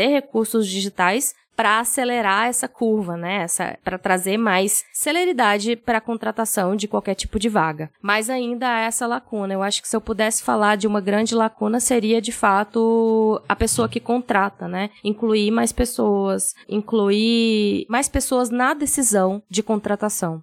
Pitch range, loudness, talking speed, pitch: 200-235 Hz, -20 LUFS, 155 wpm, 220 Hz